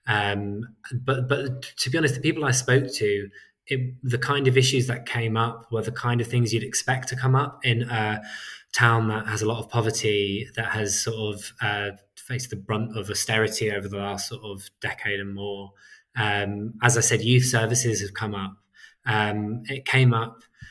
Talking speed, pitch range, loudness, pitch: 200 wpm, 105-125 Hz, -24 LUFS, 115 Hz